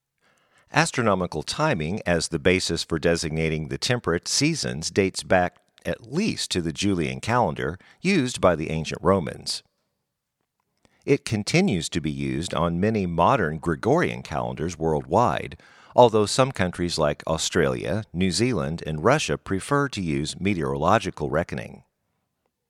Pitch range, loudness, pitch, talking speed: 80-105 Hz, -24 LUFS, 85 Hz, 125 wpm